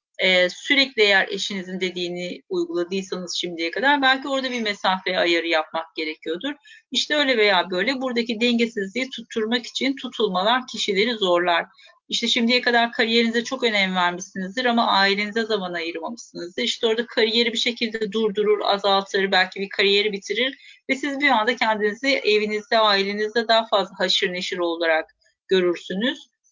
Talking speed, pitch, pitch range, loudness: 140 wpm, 215 Hz, 185-245 Hz, -21 LUFS